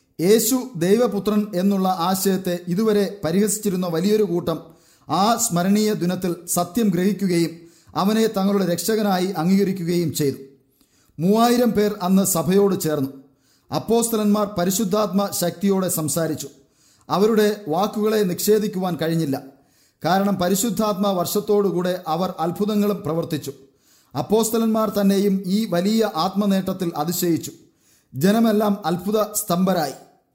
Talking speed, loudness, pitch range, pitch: 90 wpm, -21 LUFS, 165-210 Hz, 190 Hz